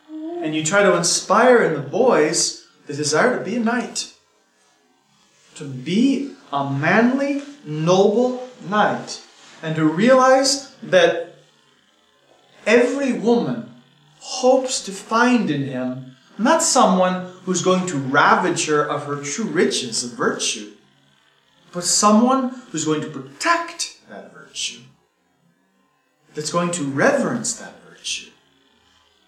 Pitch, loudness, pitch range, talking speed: 185 Hz, -19 LUFS, 155-250 Hz, 120 wpm